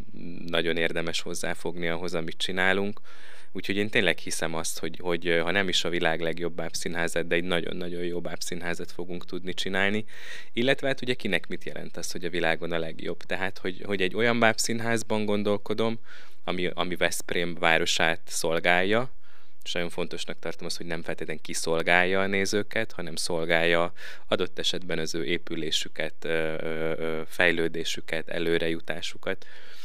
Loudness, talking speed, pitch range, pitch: -28 LUFS, 145 wpm, 85-95 Hz, 85 Hz